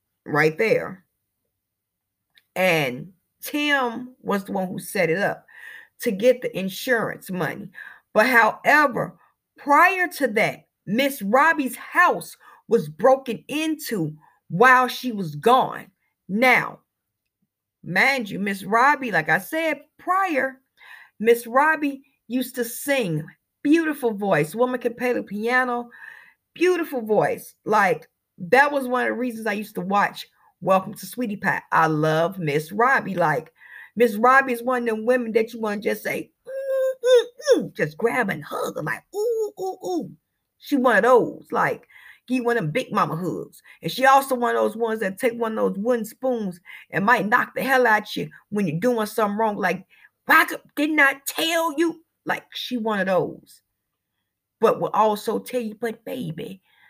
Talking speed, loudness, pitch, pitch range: 165 wpm, -22 LUFS, 245 Hz, 210-275 Hz